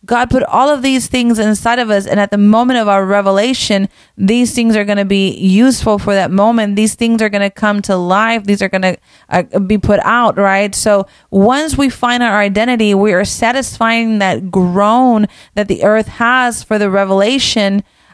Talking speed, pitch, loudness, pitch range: 200 wpm, 210 Hz, -12 LUFS, 200-235 Hz